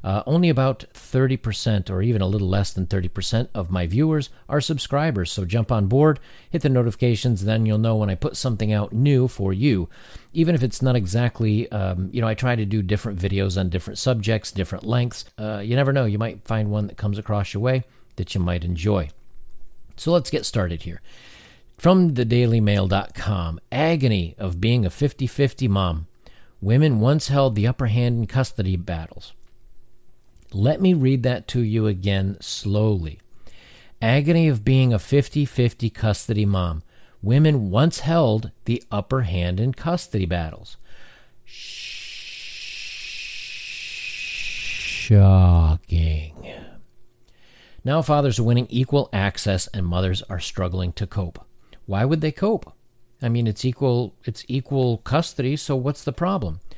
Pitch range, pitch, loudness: 95-130 Hz, 110 Hz, -22 LUFS